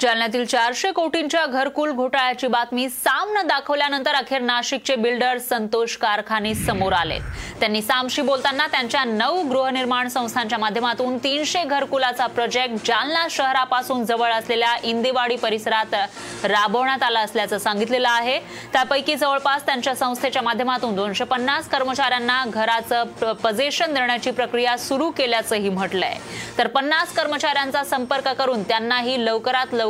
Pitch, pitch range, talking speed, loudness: 255 Hz, 235-275 Hz, 110 wpm, -21 LUFS